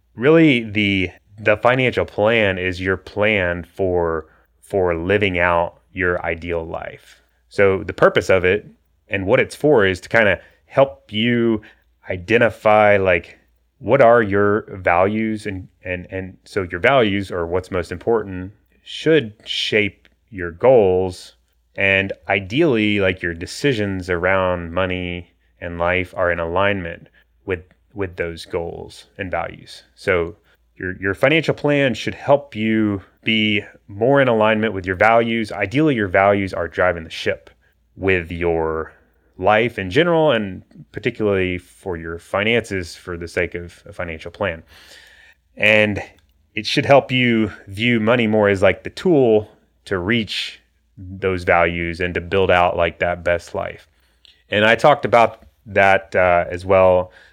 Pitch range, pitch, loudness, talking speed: 90-110 Hz, 95 Hz, -18 LUFS, 145 wpm